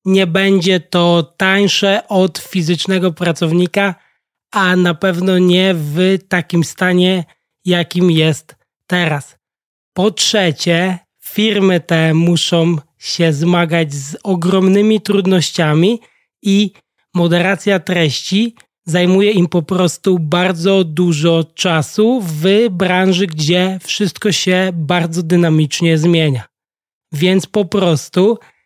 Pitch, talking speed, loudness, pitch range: 180 Hz, 100 wpm, -14 LUFS, 170-190 Hz